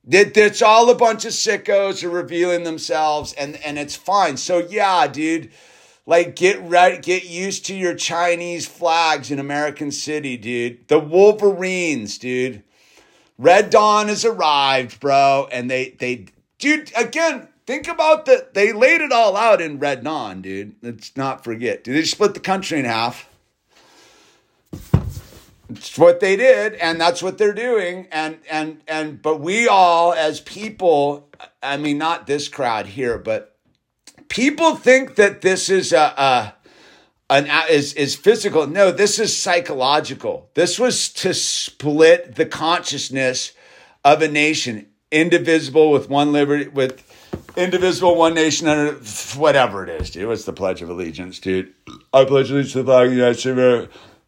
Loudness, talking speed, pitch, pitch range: -17 LUFS, 160 wpm, 160 Hz, 140-195 Hz